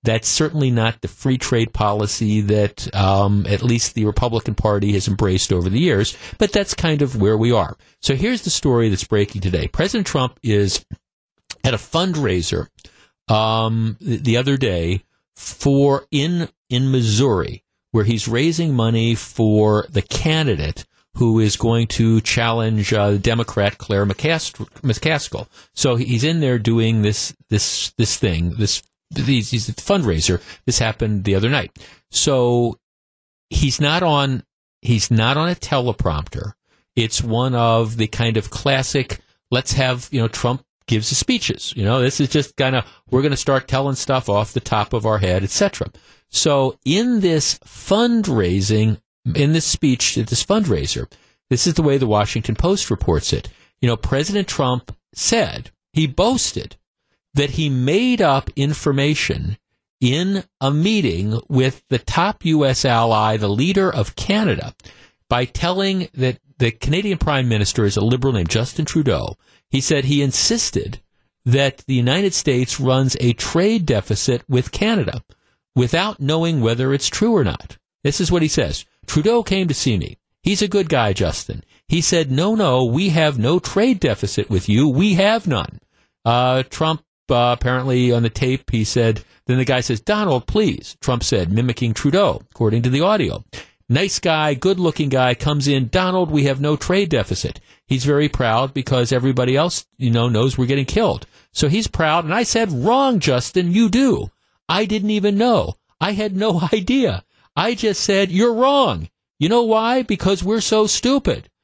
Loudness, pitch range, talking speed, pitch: -18 LUFS, 110-155 Hz, 165 wpm, 130 Hz